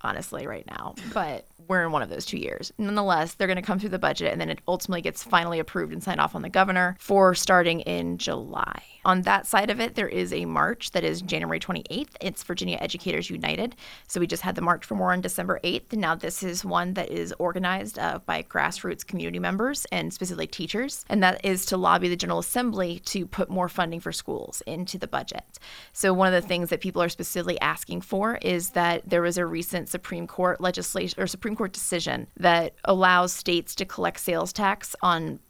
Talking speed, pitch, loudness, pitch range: 220 wpm, 180 Hz, -26 LUFS, 175-190 Hz